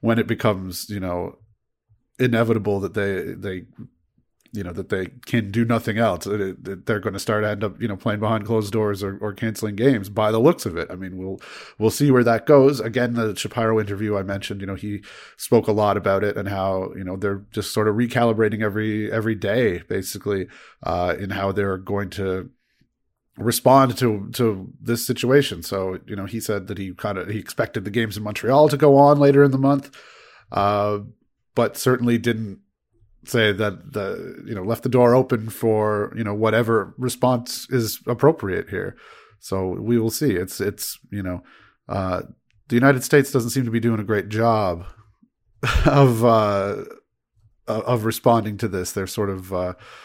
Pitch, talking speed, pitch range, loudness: 110 Hz, 190 wpm, 100-120 Hz, -21 LUFS